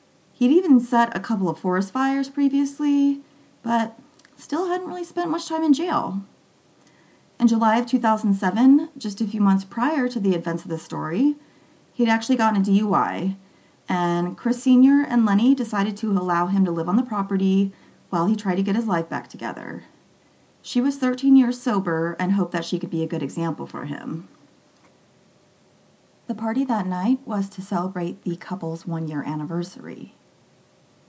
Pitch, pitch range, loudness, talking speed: 215 Hz, 180-260 Hz, -22 LUFS, 170 wpm